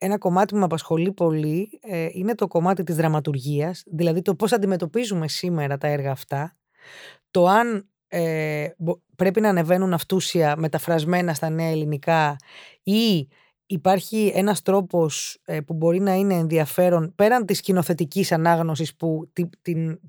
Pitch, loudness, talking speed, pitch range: 175 Hz, -22 LUFS, 130 wpm, 160-190 Hz